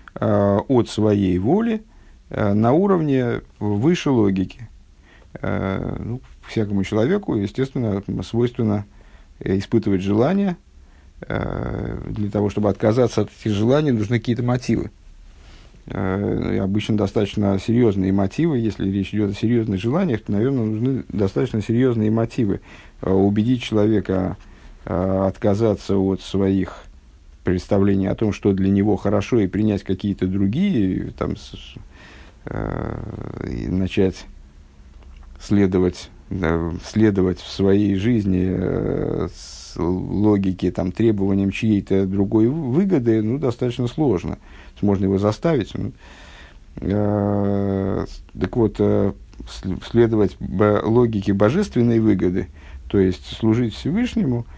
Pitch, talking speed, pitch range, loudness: 100 Hz, 105 wpm, 95-115 Hz, -20 LUFS